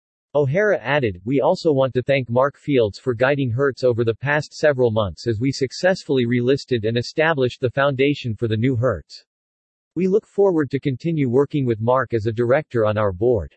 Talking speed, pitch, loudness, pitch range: 190 wpm, 130 Hz, -20 LUFS, 115-145 Hz